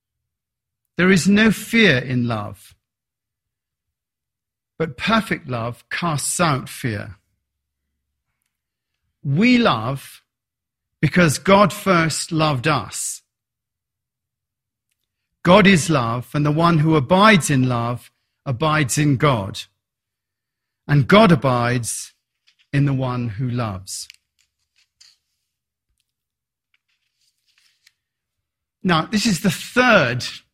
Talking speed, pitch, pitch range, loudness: 90 wpm, 130 Hz, 110-165 Hz, -18 LUFS